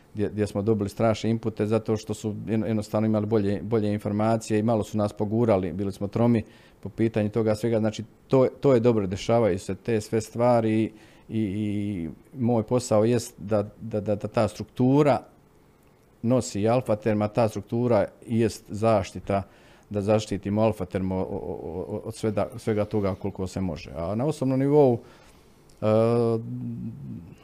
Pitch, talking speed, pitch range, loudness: 110 Hz, 150 wpm, 105-115 Hz, -25 LUFS